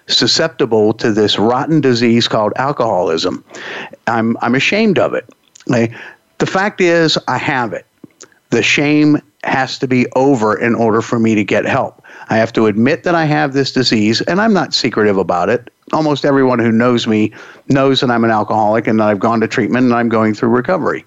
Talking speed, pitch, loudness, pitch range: 195 wpm, 120 Hz, -13 LUFS, 110-145 Hz